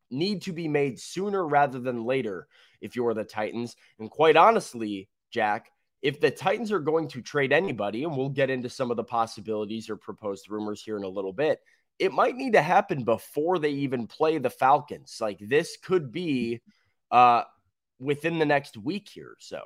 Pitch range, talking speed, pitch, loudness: 110-165 Hz, 190 wpm, 130 Hz, -26 LUFS